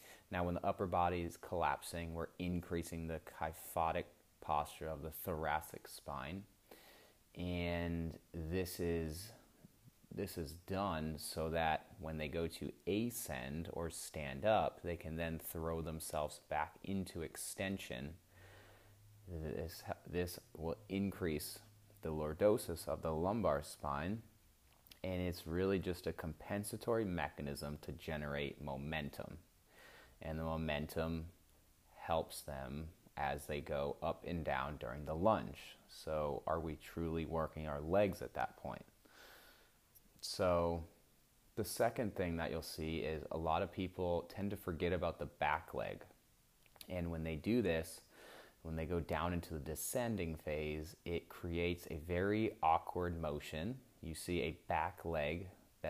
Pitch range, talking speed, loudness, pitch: 80-95 Hz, 135 wpm, -41 LUFS, 85 Hz